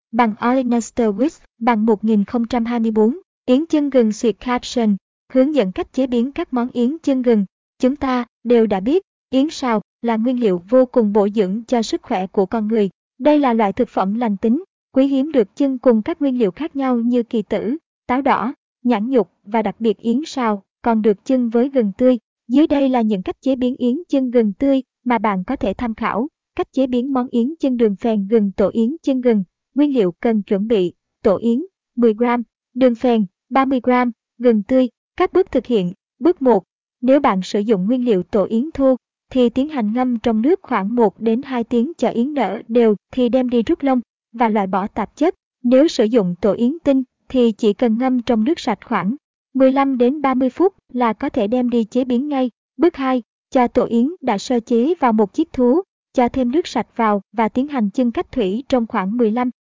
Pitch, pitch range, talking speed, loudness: 245 Hz, 225-265 Hz, 210 wpm, -18 LUFS